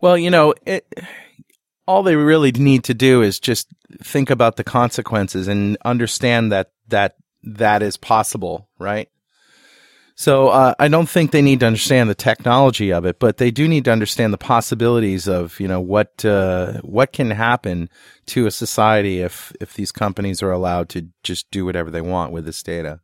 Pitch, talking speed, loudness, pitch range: 110 Hz, 185 wpm, -17 LUFS, 95-130 Hz